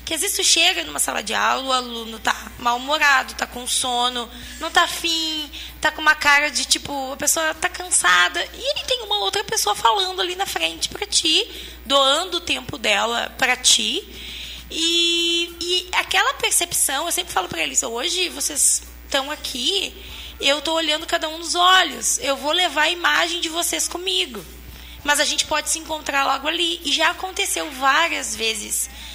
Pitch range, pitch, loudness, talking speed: 275-355 Hz, 315 Hz, -19 LUFS, 175 wpm